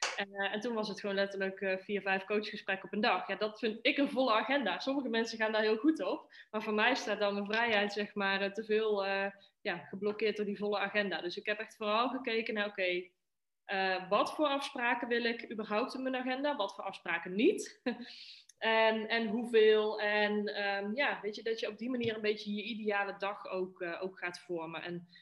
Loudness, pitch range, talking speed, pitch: -34 LUFS, 195-230 Hz, 220 wpm, 210 Hz